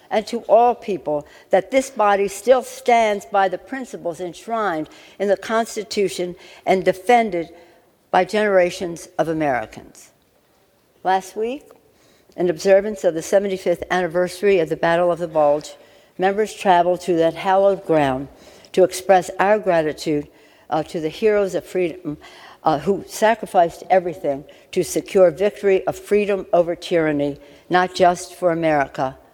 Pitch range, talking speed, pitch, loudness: 170-200 Hz, 135 wpm, 185 Hz, -19 LUFS